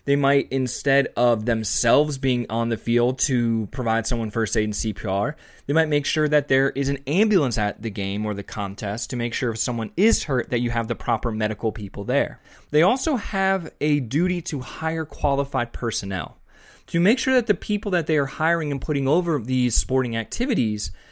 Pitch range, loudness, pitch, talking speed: 115-150 Hz, -23 LUFS, 130 Hz, 200 wpm